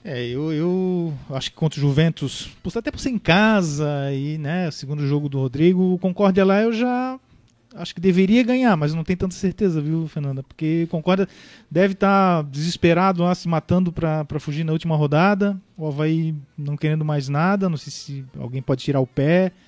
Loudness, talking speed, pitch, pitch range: -21 LUFS, 195 wpm, 165 Hz, 150-190 Hz